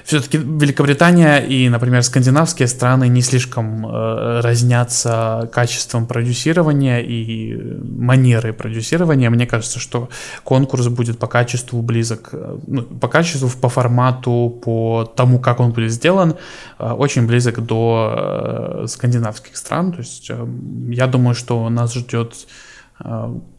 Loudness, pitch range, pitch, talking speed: -16 LUFS, 115-130 Hz, 120 Hz, 125 wpm